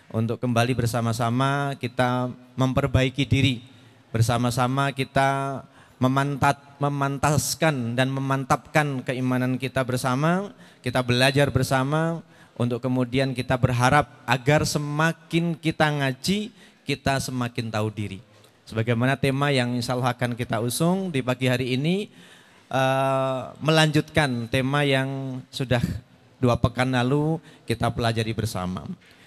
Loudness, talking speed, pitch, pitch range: -24 LUFS, 110 wpm, 130 Hz, 125-140 Hz